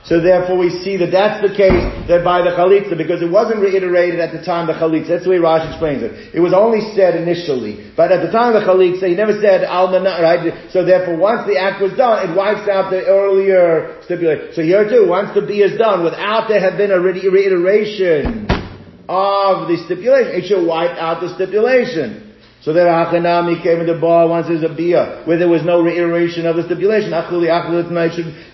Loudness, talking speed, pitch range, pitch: -14 LUFS, 220 wpm, 170-195 Hz, 180 Hz